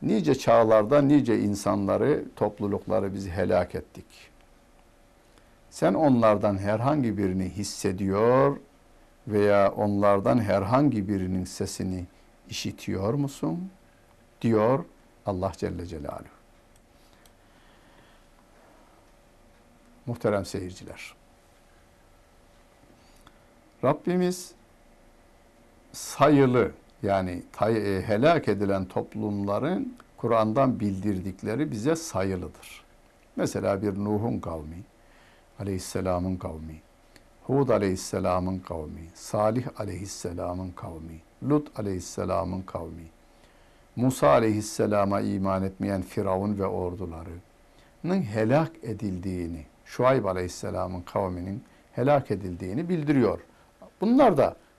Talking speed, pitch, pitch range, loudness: 75 wpm, 100 Hz, 95-115 Hz, -26 LUFS